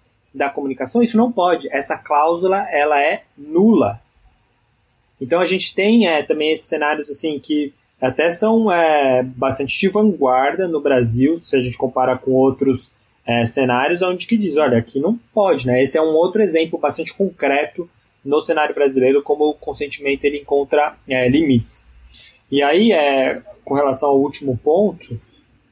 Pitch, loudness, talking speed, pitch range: 145 Hz, -17 LUFS, 160 wpm, 130-170 Hz